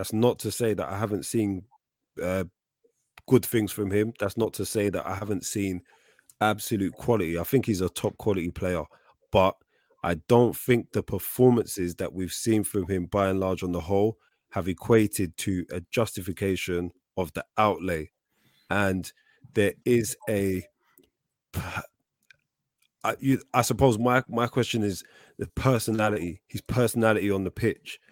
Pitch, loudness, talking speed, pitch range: 105 Hz, -27 LUFS, 155 wpm, 95-115 Hz